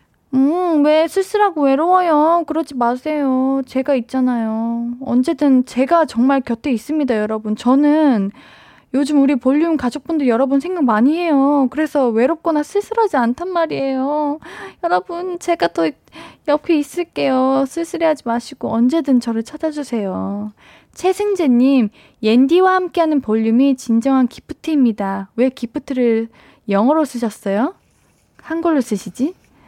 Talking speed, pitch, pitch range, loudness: 295 characters per minute, 275 Hz, 240-315 Hz, -17 LUFS